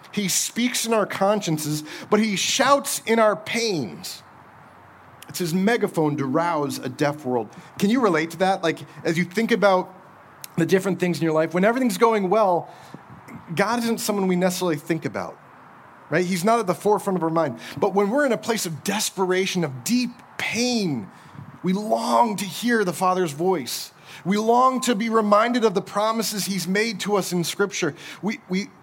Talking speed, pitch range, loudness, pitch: 185 wpm, 170-220 Hz, -22 LUFS, 195 Hz